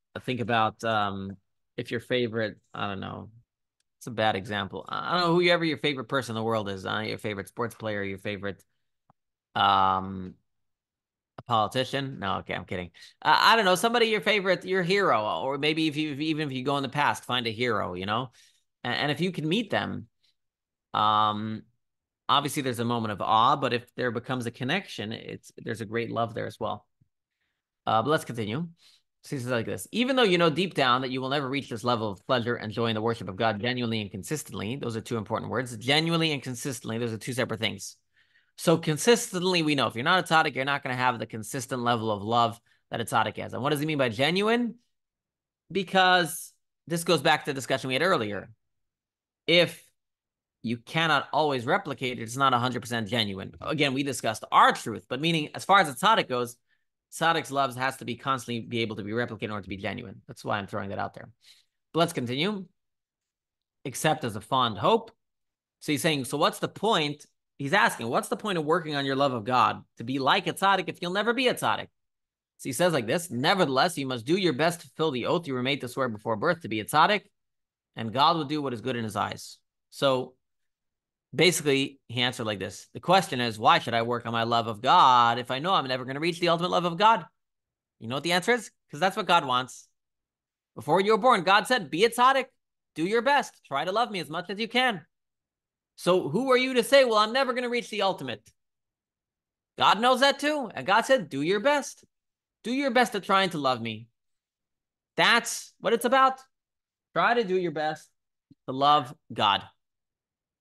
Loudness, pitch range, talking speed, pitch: -26 LUFS, 115-170 Hz, 215 wpm, 135 Hz